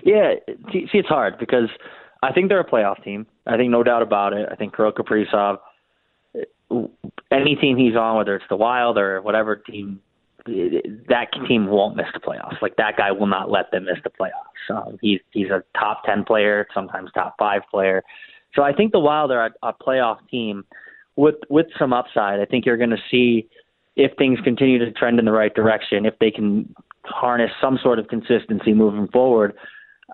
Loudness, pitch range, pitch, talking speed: -20 LUFS, 105-140 Hz, 120 Hz, 195 wpm